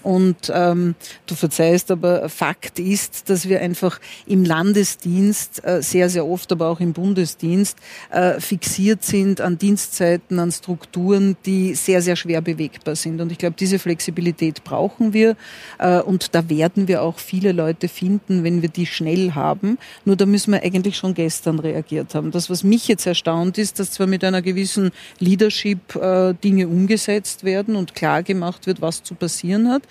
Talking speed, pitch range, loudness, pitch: 175 wpm, 170-195 Hz, -19 LUFS, 180 Hz